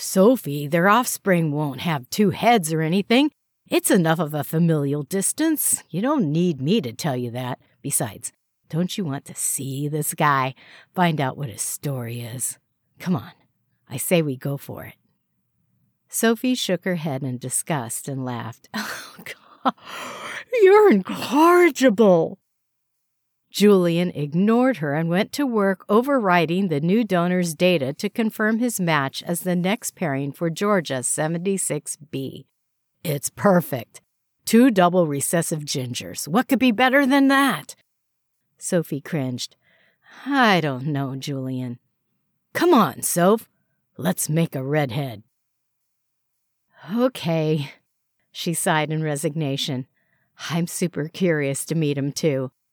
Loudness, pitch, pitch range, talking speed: -21 LUFS, 165 Hz, 140-200 Hz, 135 wpm